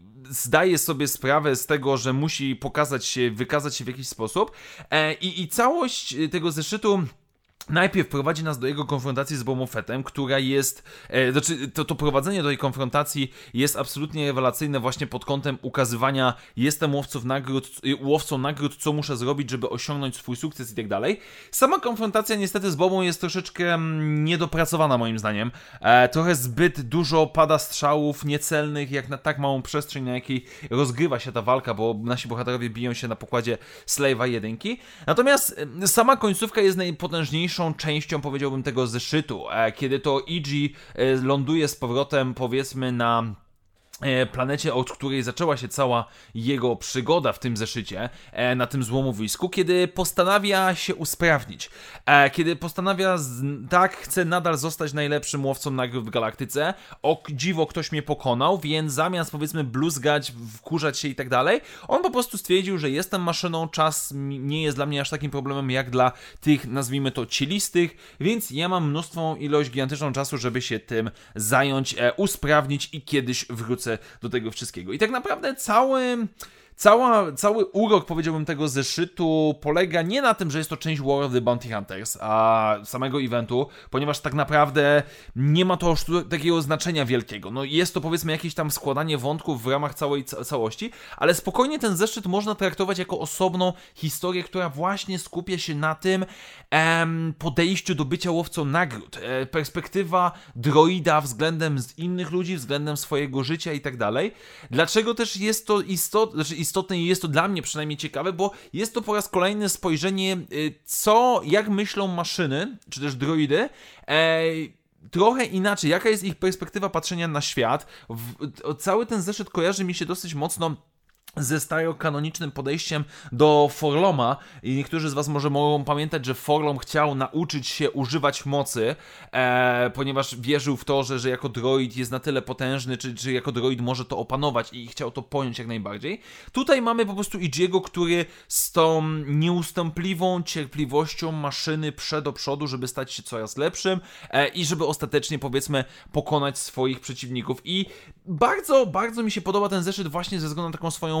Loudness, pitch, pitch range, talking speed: -24 LUFS, 150 Hz, 135-175 Hz, 160 wpm